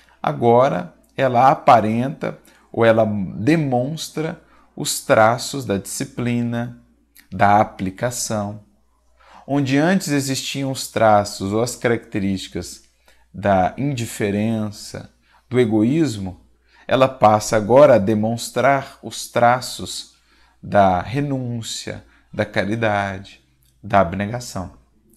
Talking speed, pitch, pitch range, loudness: 90 wpm, 115 Hz, 100-125 Hz, -19 LUFS